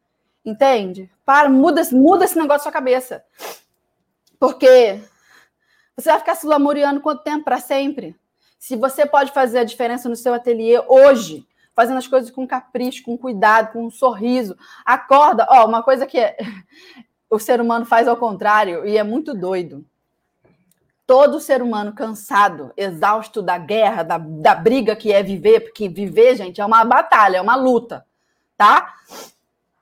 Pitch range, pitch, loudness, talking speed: 215-270 Hz, 240 Hz, -16 LUFS, 155 wpm